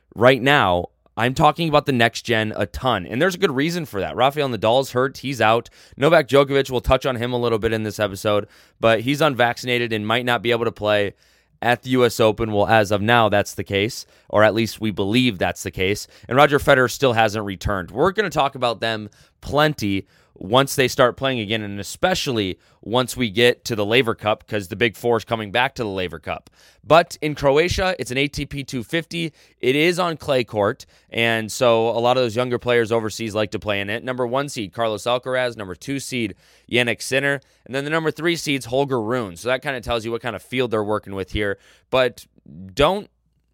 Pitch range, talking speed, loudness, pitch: 105-135 Hz, 220 wpm, -20 LUFS, 120 Hz